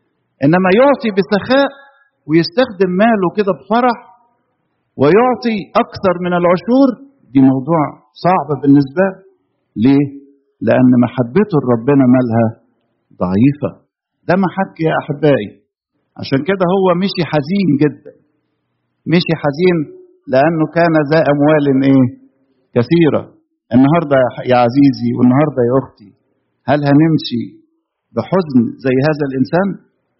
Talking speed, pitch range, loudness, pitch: 105 wpm, 135-190 Hz, -13 LUFS, 150 Hz